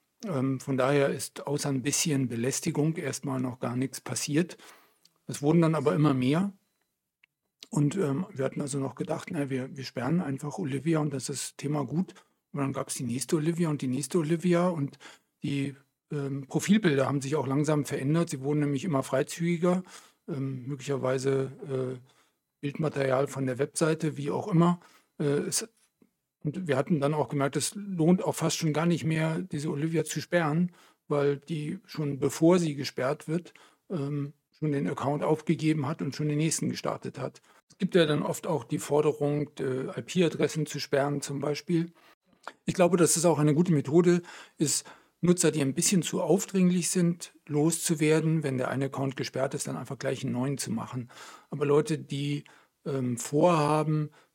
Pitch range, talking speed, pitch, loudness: 140-165 Hz, 175 wpm, 150 Hz, -29 LUFS